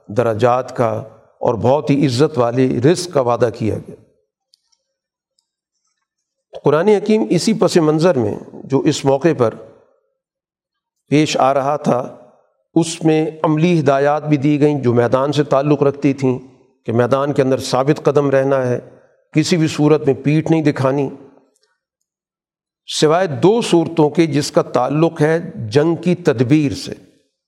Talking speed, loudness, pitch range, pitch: 145 wpm, -16 LUFS, 135-170 Hz, 150 Hz